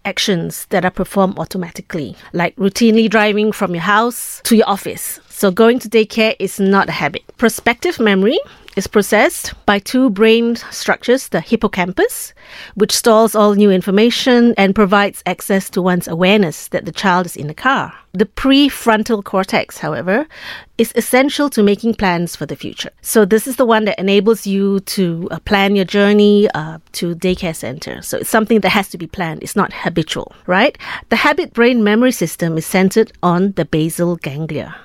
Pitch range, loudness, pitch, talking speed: 180-225 Hz, -15 LUFS, 200 Hz, 175 wpm